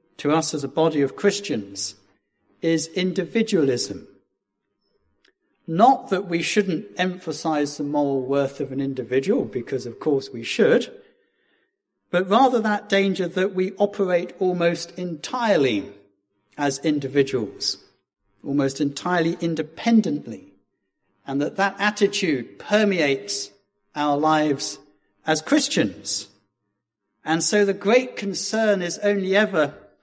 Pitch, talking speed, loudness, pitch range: 165 Hz, 110 wpm, -22 LUFS, 135-200 Hz